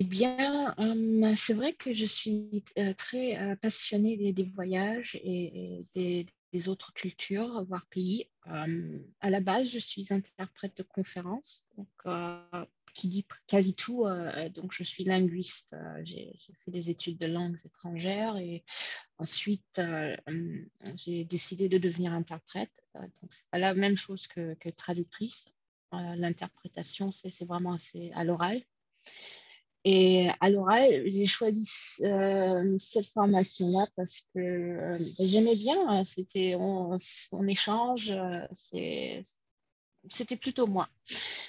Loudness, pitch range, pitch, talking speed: -31 LUFS, 175-210 Hz, 190 Hz, 140 wpm